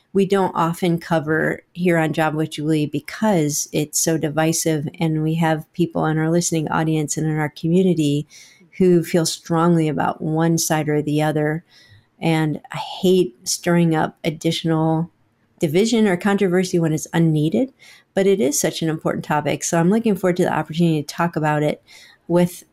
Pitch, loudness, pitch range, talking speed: 165 Hz, -20 LUFS, 155-175 Hz, 170 wpm